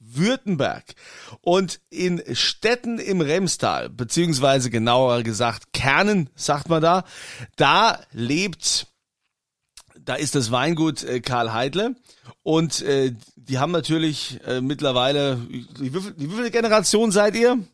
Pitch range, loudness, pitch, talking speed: 130-185 Hz, -21 LUFS, 150 Hz, 115 wpm